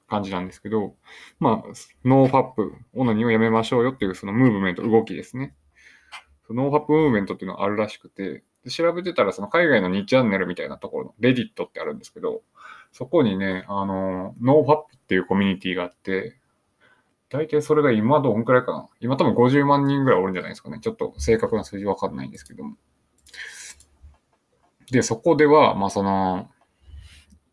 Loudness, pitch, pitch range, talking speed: -22 LUFS, 110 Hz, 95-135 Hz, 425 characters per minute